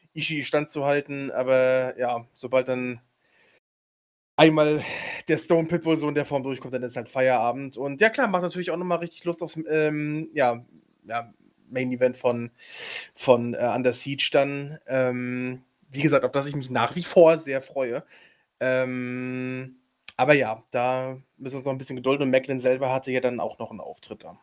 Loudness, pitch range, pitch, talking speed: -25 LUFS, 125-150 Hz, 130 Hz, 185 wpm